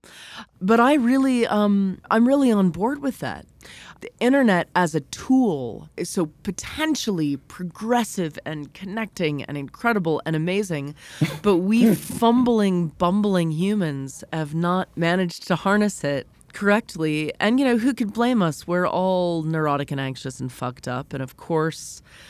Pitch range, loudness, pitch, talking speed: 155-220 Hz, -22 LUFS, 180 Hz, 150 wpm